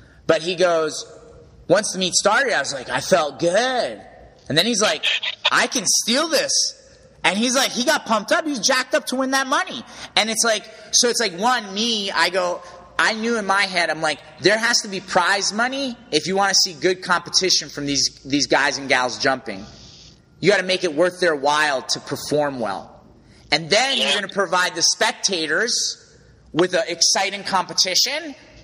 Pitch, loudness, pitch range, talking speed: 190 Hz, -19 LUFS, 165-235 Hz, 195 wpm